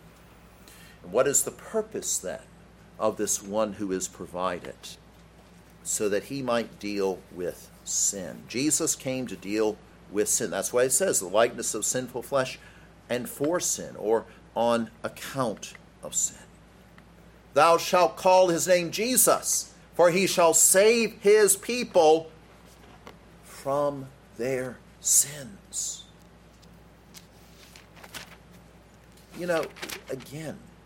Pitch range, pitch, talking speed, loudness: 110-180 Hz, 140 Hz, 115 wpm, -25 LUFS